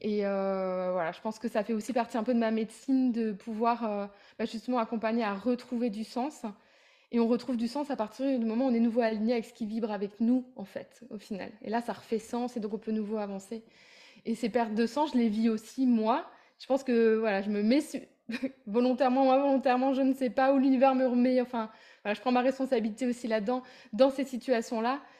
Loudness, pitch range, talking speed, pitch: -30 LUFS, 220-255 Hz, 240 wpm, 235 Hz